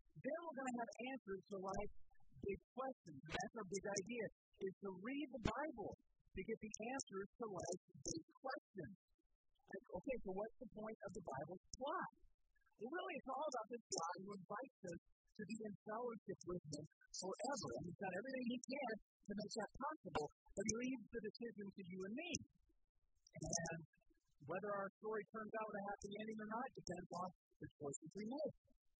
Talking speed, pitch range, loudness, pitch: 190 wpm, 185-245 Hz, -46 LUFS, 210 Hz